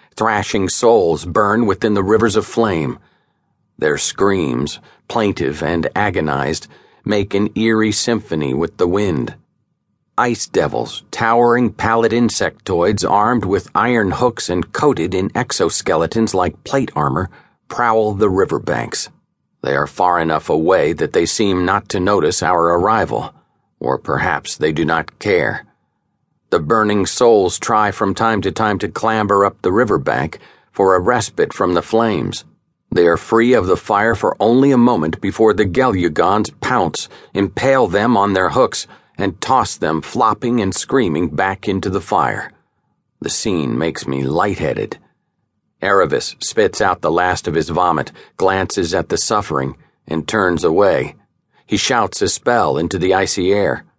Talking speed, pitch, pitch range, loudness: 150 wpm, 105 Hz, 95-115 Hz, -16 LUFS